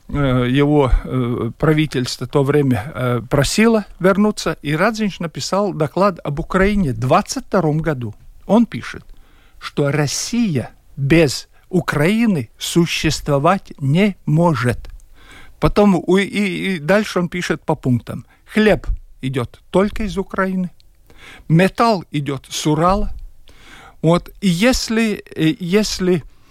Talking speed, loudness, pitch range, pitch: 105 wpm, -17 LUFS, 145-195 Hz, 170 Hz